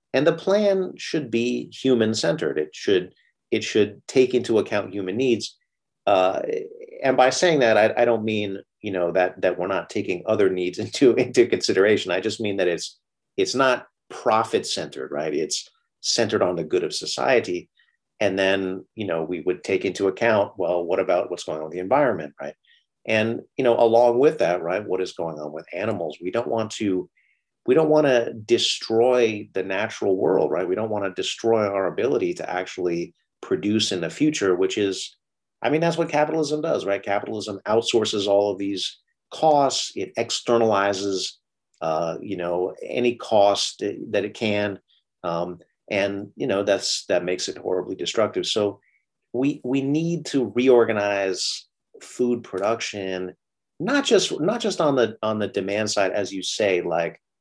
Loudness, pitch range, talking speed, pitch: -23 LUFS, 100-160 Hz, 175 wpm, 115 Hz